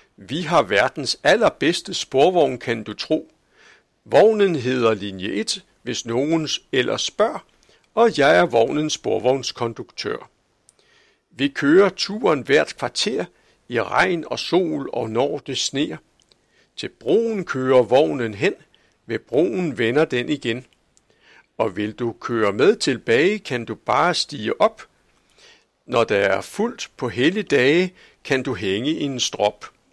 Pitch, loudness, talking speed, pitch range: 130 Hz, -20 LUFS, 135 wpm, 115-160 Hz